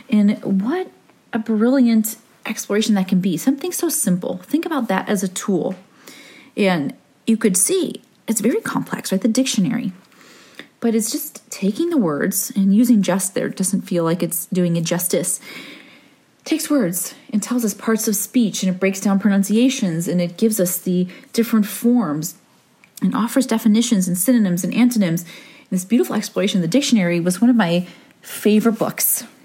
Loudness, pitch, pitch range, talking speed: -19 LUFS, 220 Hz, 190-245 Hz, 175 wpm